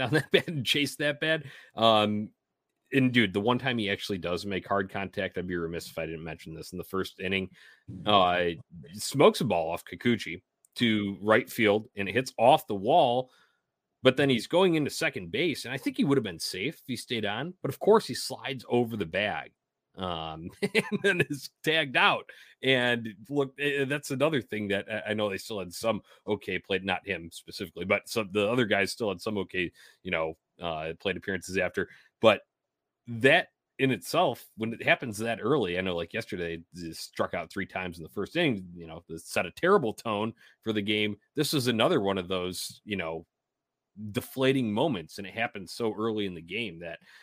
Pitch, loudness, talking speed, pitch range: 110 Hz, -28 LUFS, 205 wpm, 95-135 Hz